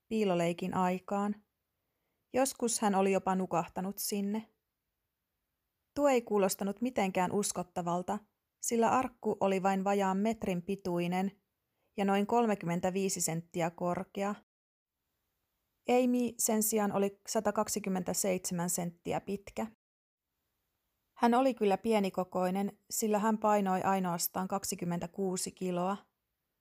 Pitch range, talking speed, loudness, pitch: 180-215 Hz, 95 wpm, -32 LUFS, 195 Hz